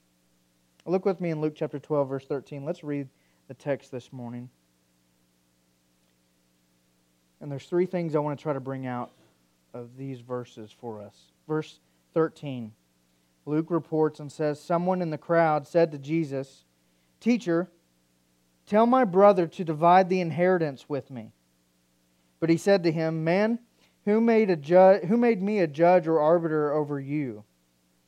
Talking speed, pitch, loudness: 155 wpm, 145 Hz, -25 LUFS